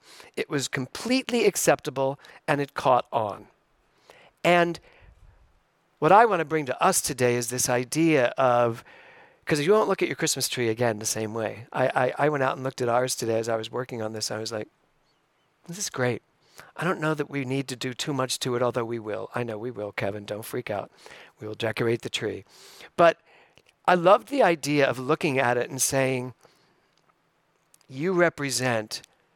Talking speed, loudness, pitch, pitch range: 195 wpm, -25 LUFS, 130 Hz, 115-160 Hz